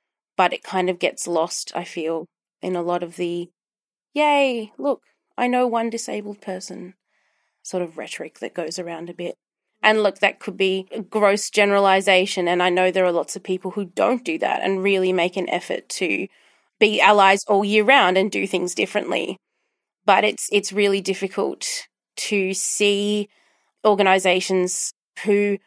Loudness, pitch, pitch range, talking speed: -20 LUFS, 195 Hz, 180-210 Hz, 170 wpm